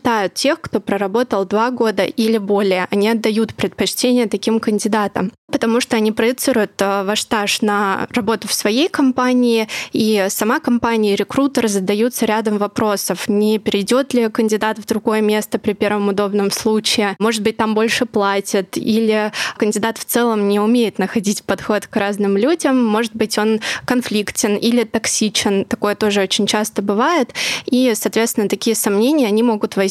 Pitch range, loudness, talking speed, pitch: 205-235 Hz, -17 LUFS, 155 wpm, 220 Hz